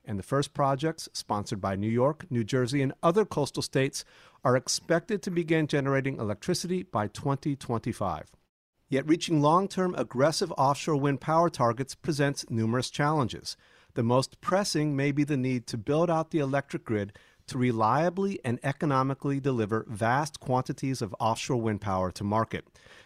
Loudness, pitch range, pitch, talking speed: -28 LUFS, 115-155 Hz, 135 Hz, 155 wpm